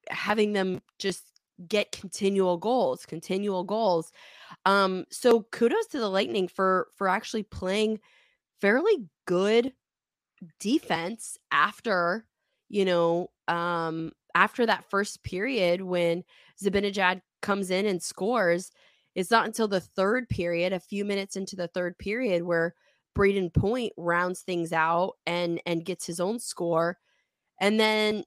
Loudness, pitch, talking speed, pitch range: -27 LUFS, 190 Hz, 130 wpm, 175-210 Hz